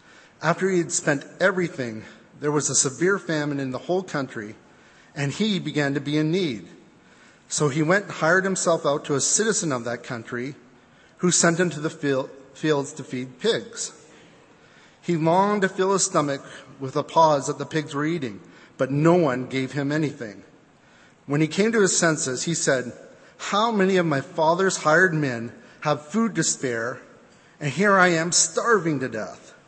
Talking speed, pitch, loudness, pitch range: 180 wpm, 155 Hz, -23 LUFS, 140-180 Hz